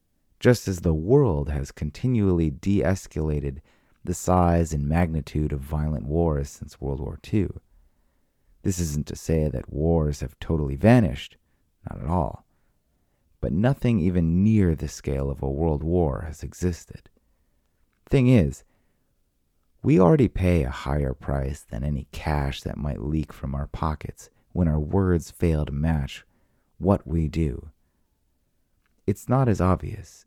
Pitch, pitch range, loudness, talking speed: 80 Hz, 75-90 Hz, -24 LUFS, 145 wpm